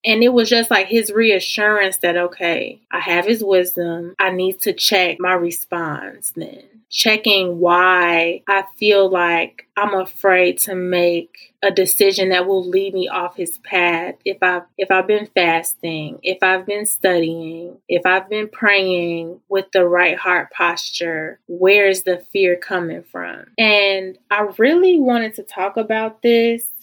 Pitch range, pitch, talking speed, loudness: 175-210 Hz, 190 Hz, 160 wpm, -16 LUFS